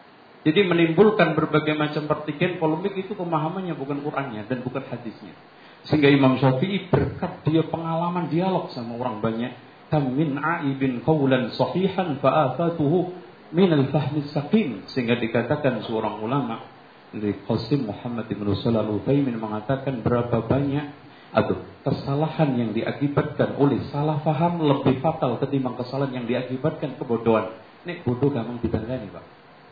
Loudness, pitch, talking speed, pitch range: -24 LUFS, 140 Hz, 125 wpm, 120-155 Hz